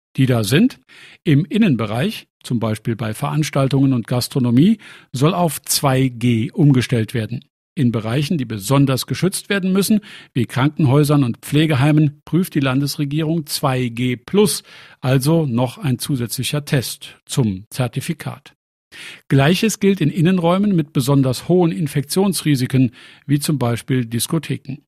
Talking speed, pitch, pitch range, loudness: 125 wpm, 140 Hz, 125-160 Hz, -18 LUFS